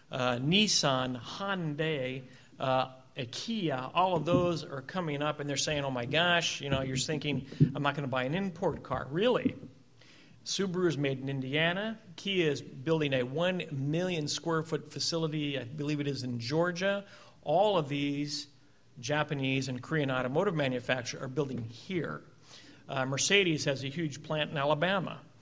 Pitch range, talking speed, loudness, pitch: 135-165 Hz, 160 wpm, -31 LUFS, 145 Hz